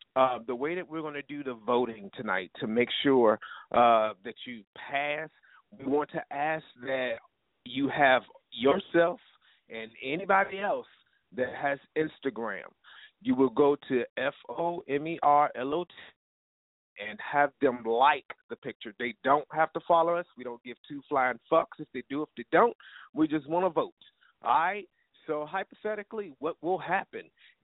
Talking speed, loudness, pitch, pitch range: 175 wpm, -29 LUFS, 150 Hz, 130-170 Hz